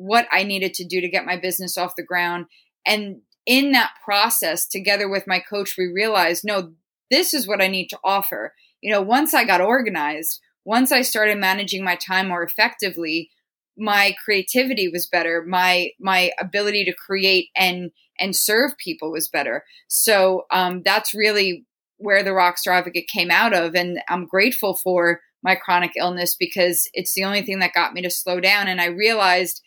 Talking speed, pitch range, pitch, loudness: 185 wpm, 180-205 Hz, 190 Hz, -19 LUFS